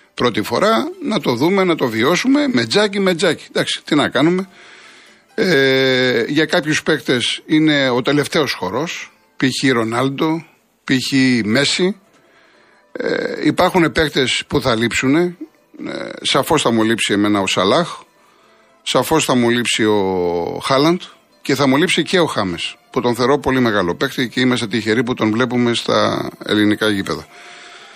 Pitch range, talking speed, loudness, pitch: 120-165 Hz, 150 wpm, -16 LUFS, 135 Hz